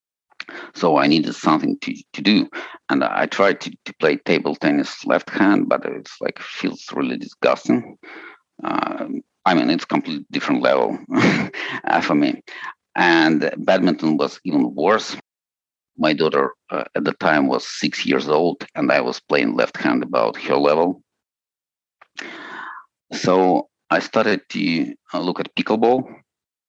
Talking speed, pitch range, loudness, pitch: 140 wpm, 275-320 Hz, -20 LUFS, 290 Hz